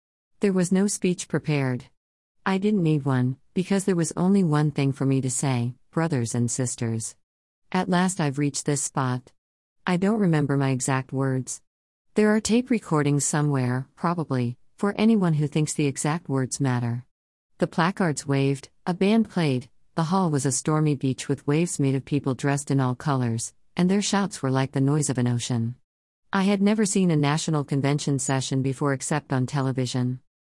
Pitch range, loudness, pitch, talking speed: 130-170 Hz, -24 LUFS, 140 Hz, 180 wpm